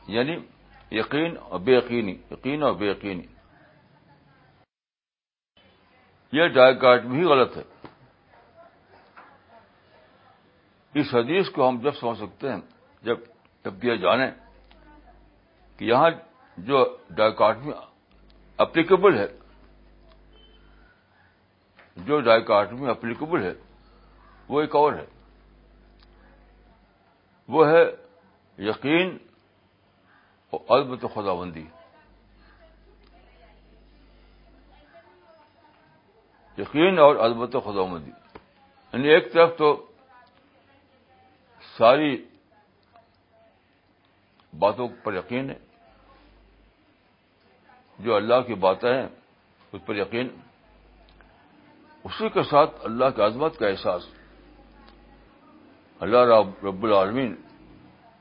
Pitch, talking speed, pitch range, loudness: 115 Hz, 85 wpm, 100-145 Hz, -22 LUFS